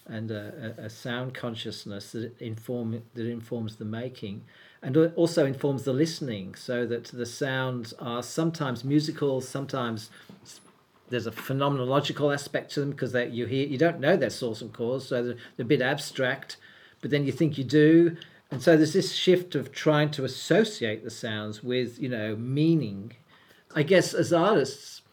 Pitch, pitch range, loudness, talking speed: 130 Hz, 120-150 Hz, -27 LUFS, 170 wpm